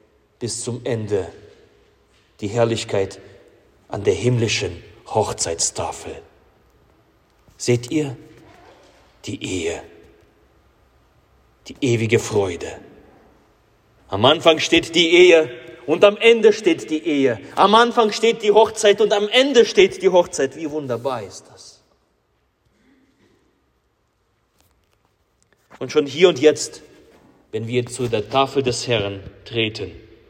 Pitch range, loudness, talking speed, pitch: 115-180 Hz, -18 LUFS, 110 wpm, 135 Hz